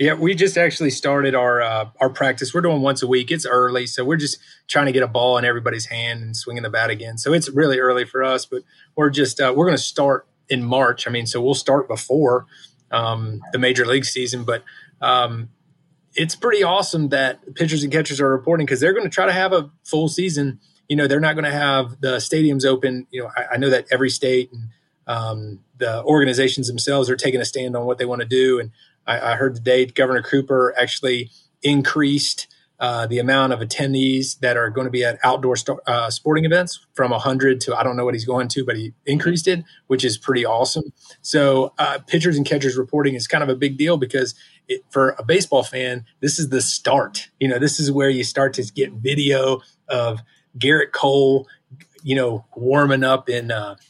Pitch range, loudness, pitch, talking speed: 125-145 Hz, -19 LUFS, 130 Hz, 220 wpm